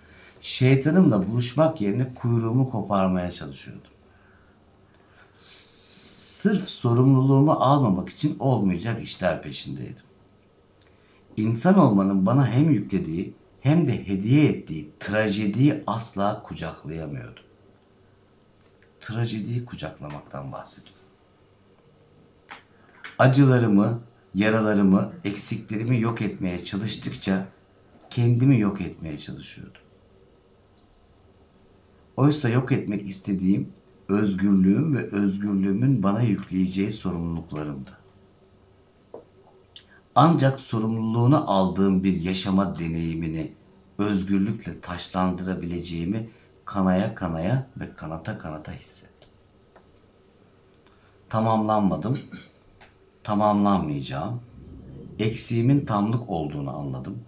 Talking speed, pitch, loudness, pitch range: 70 wpm, 100 Hz, -24 LUFS, 95-115 Hz